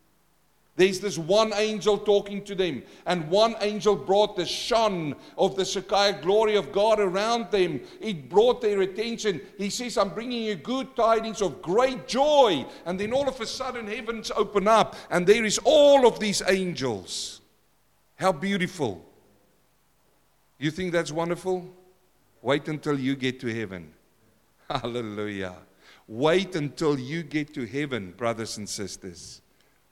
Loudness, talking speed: -25 LUFS, 145 wpm